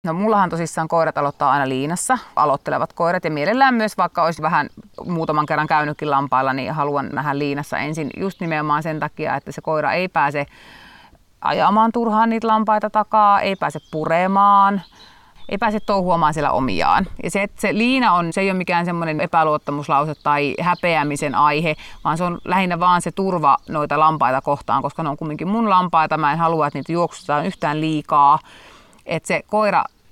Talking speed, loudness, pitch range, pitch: 175 wpm, -19 LUFS, 150-195 Hz, 165 Hz